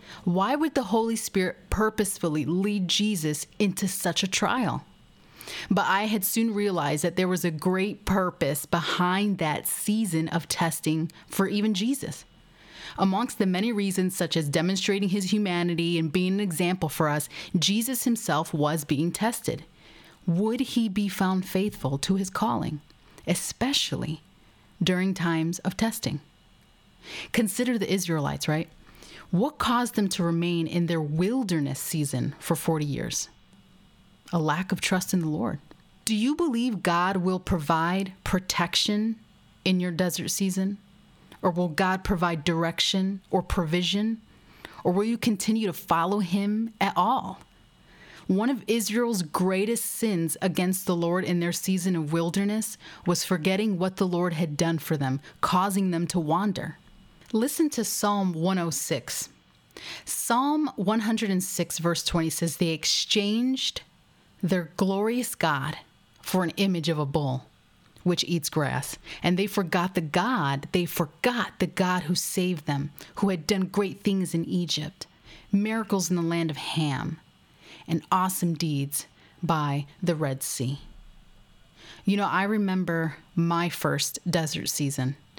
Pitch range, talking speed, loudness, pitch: 165-205 Hz, 145 wpm, -26 LUFS, 185 Hz